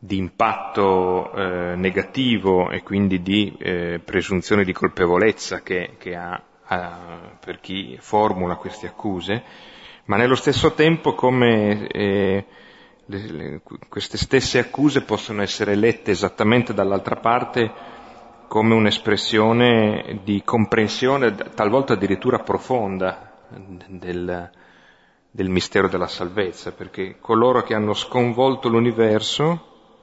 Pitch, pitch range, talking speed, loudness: 105 Hz, 95-115 Hz, 110 wpm, -20 LUFS